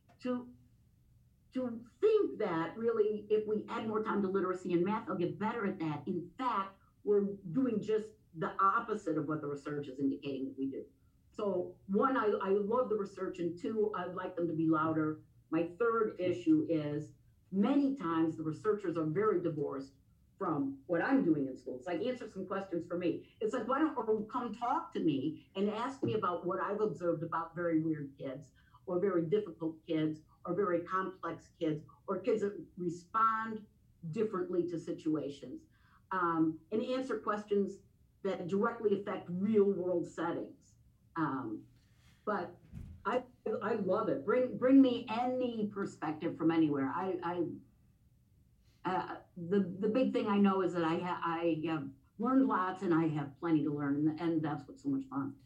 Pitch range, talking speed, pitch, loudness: 160-215 Hz, 175 wpm, 185 Hz, -35 LUFS